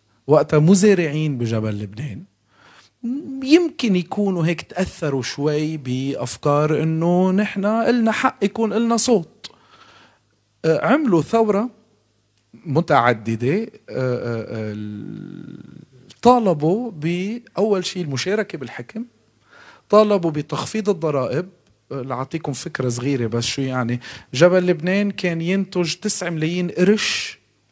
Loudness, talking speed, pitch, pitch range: -20 LUFS, 90 wpm, 165 Hz, 135-205 Hz